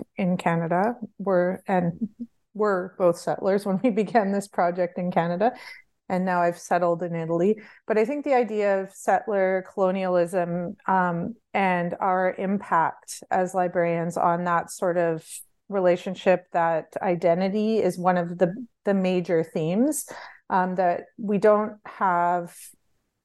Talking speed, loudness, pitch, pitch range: 135 wpm, -24 LUFS, 185 Hz, 175-205 Hz